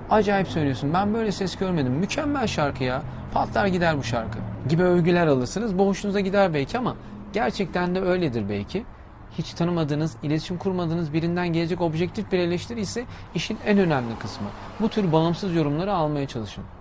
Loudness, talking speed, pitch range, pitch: -24 LUFS, 155 wpm, 140-195 Hz, 170 Hz